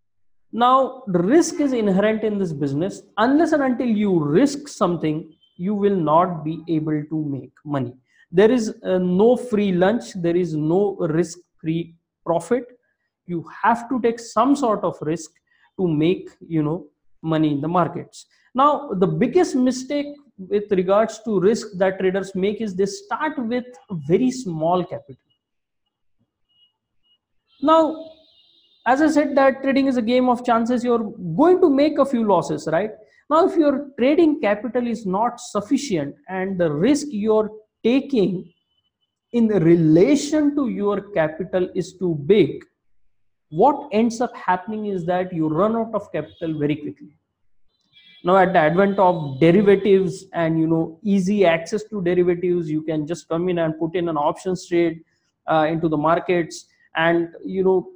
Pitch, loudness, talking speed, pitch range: 190 Hz, -20 LUFS, 160 wpm, 165-240 Hz